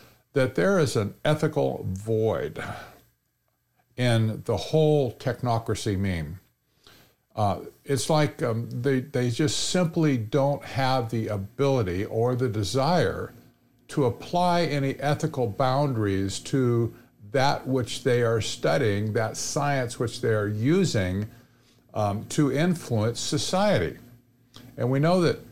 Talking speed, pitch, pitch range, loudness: 120 wpm, 125 Hz, 115-145 Hz, -26 LUFS